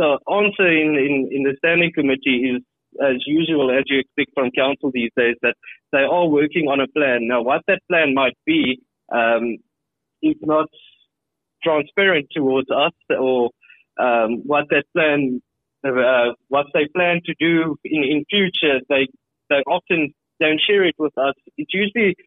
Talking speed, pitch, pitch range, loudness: 165 wpm, 145 Hz, 135-165 Hz, -19 LUFS